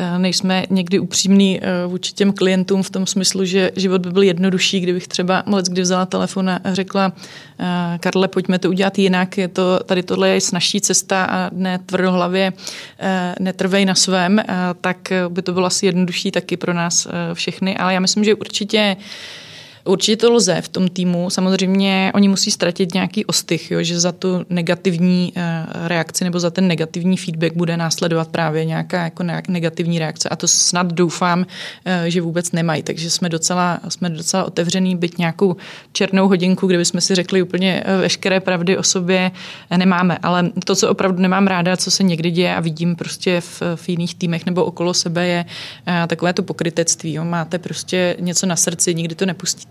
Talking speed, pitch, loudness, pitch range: 175 wpm, 180 Hz, -17 LUFS, 175-190 Hz